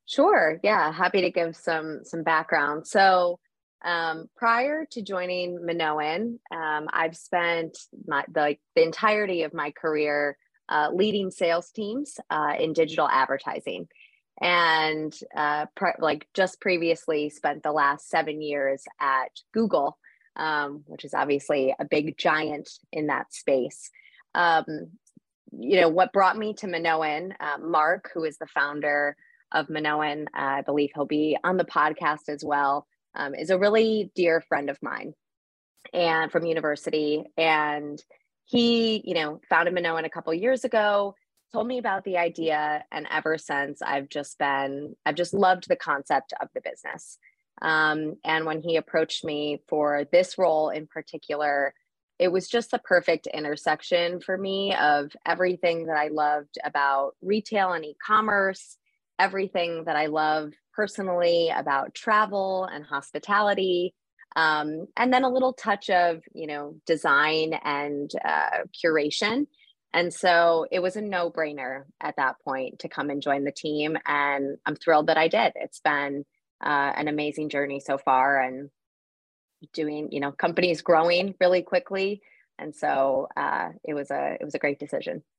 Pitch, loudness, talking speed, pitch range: 160 Hz, -25 LUFS, 155 wpm, 150-185 Hz